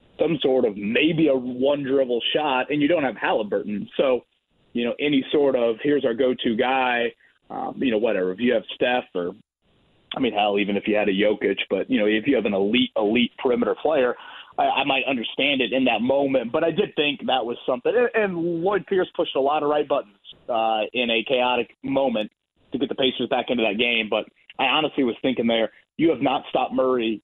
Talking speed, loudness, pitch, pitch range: 220 wpm, -22 LUFS, 130 Hz, 115-150 Hz